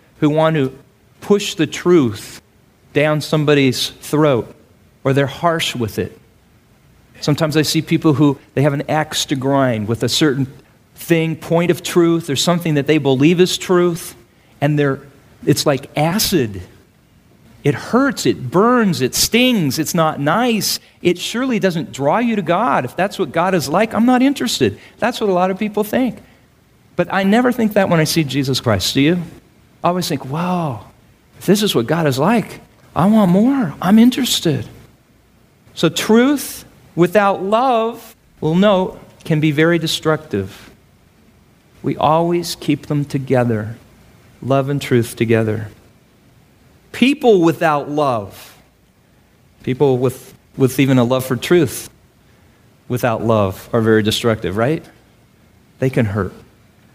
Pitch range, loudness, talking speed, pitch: 125-180 Hz, -16 LUFS, 150 wpm, 150 Hz